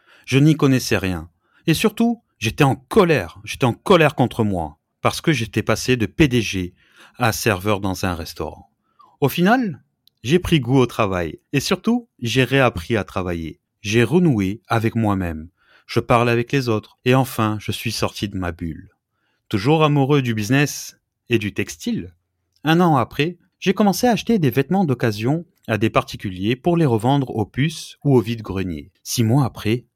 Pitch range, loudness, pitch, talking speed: 105-145 Hz, -20 LUFS, 120 Hz, 170 wpm